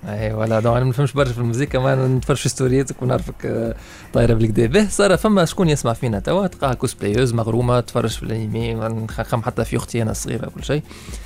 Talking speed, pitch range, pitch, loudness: 190 wpm, 115-140 Hz, 120 Hz, -19 LUFS